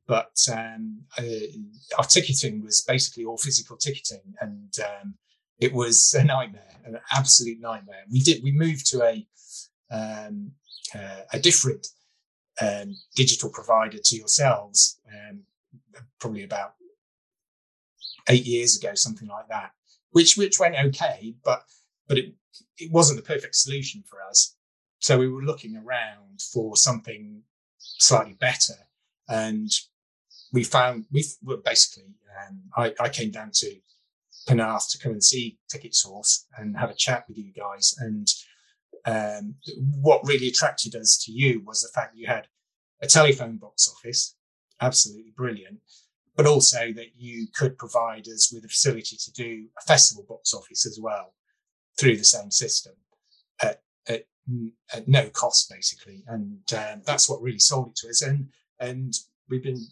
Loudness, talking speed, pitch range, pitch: -21 LUFS, 155 wpm, 115-150 Hz, 125 Hz